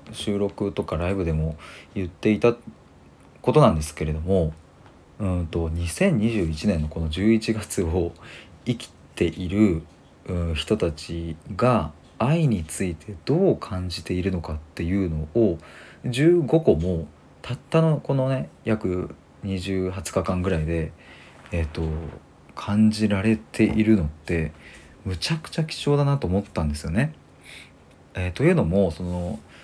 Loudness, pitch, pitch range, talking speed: -24 LUFS, 90 Hz, 80-110 Hz, 240 characters per minute